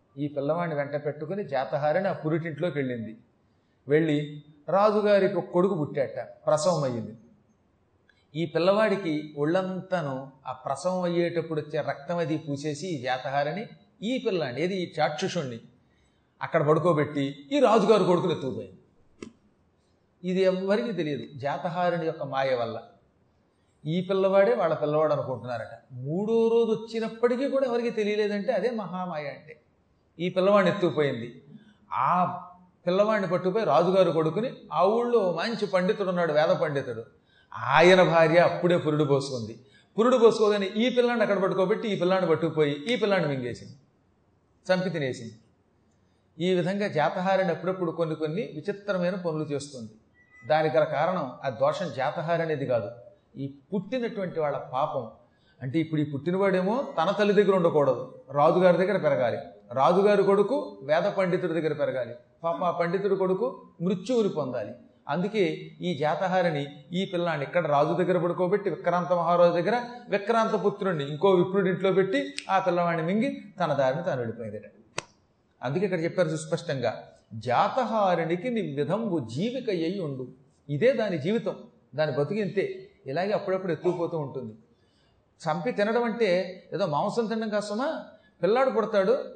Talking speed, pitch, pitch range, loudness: 125 wpm, 175 Hz, 145-195 Hz, -26 LUFS